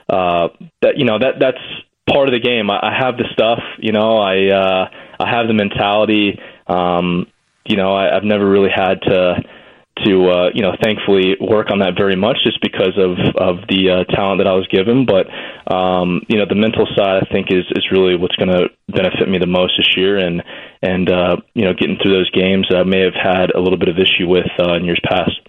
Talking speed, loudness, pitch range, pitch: 230 wpm, -14 LUFS, 90-100 Hz, 95 Hz